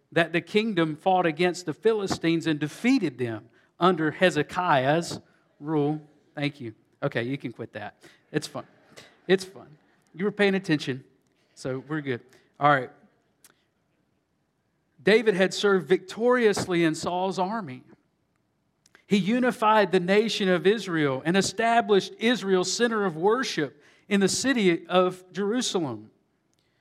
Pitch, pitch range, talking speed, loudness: 180 Hz, 150-200 Hz, 130 wpm, -25 LUFS